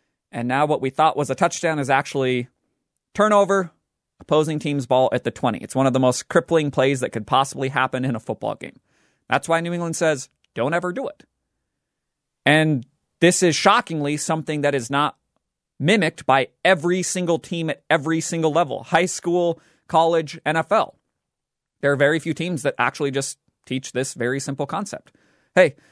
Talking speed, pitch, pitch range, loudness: 175 wpm, 155 Hz, 135-170 Hz, -21 LUFS